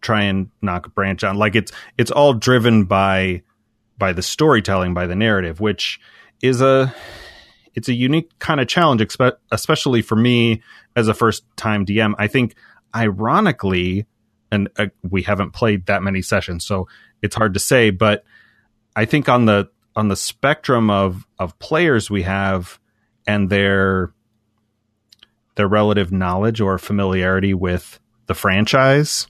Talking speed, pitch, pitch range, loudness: 155 wpm, 105 Hz, 95-115 Hz, -18 LUFS